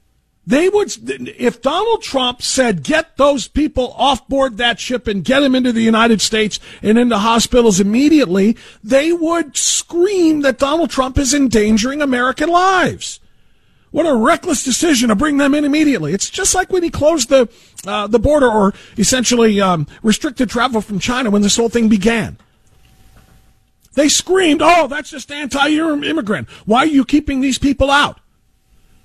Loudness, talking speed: -14 LUFS, 160 wpm